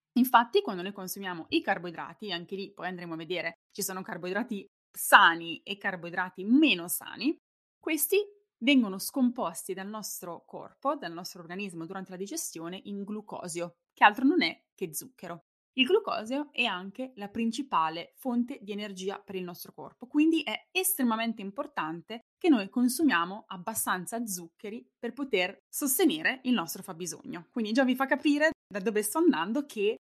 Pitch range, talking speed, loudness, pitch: 185-270 Hz, 160 wpm, -29 LUFS, 215 Hz